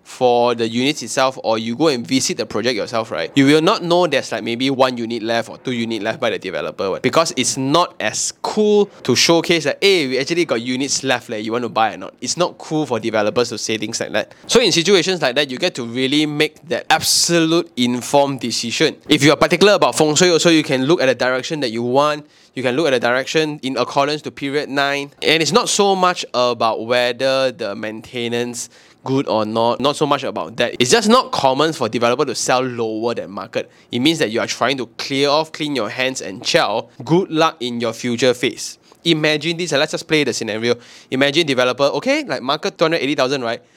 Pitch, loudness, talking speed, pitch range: 135 Hz, -17 LUFS, 230 wpm, 120-160 Hz